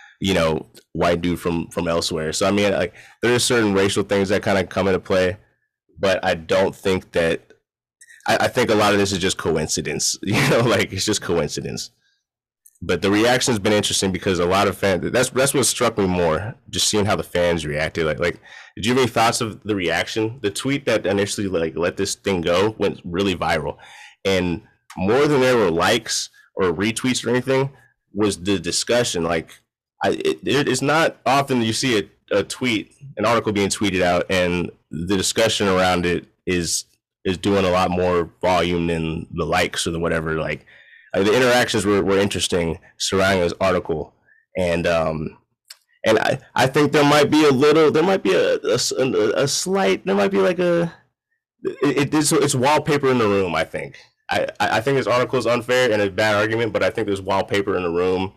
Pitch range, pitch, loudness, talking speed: 90-125 Hz, 100 Hz, -20 LUFS, 205 wpm